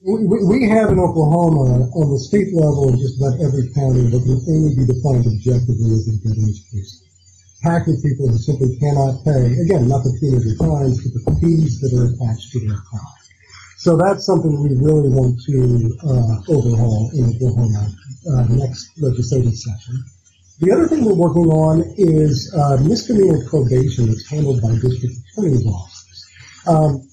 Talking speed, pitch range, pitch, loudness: 165 wpm, 115-155 Hz, 130 Hz, -16 LUFS